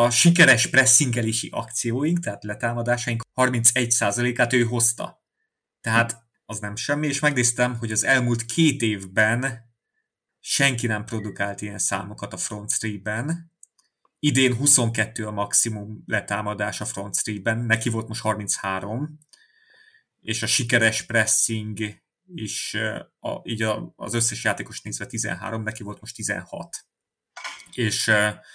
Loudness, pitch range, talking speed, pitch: -22 LUFS, 105-125 Hz, 120 wpm, 115 Hz